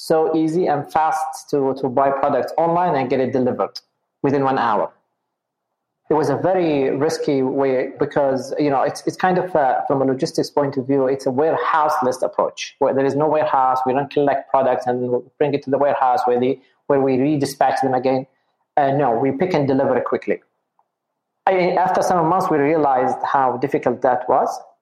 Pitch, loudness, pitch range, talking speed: 140 Hz, -19 LUFS, 135-155 Hz, 200 wpm